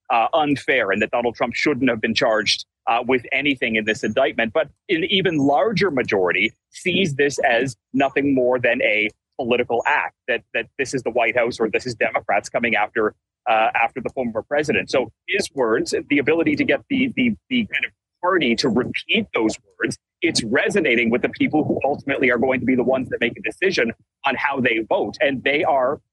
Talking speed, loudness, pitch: 205 wpm, -20 LUFS, 140 Hz